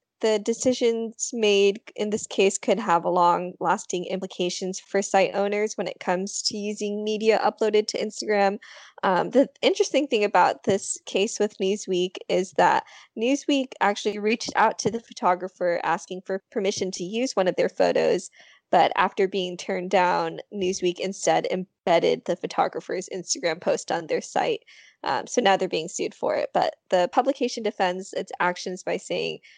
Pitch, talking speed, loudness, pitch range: 200 Hz, 165 wpm, -24 LUFS, 185-225 Hz